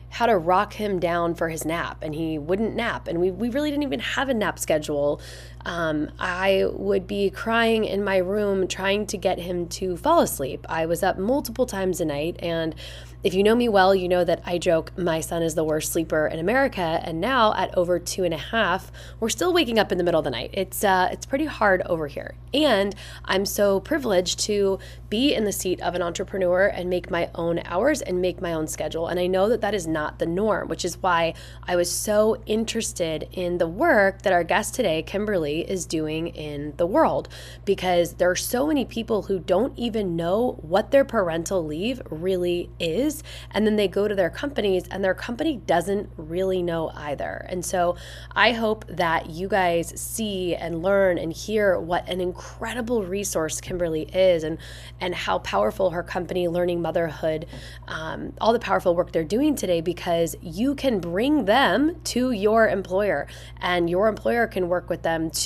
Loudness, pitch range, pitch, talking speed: -24 LUFS, 170-210 Hz, 185 Hz, 200 wpm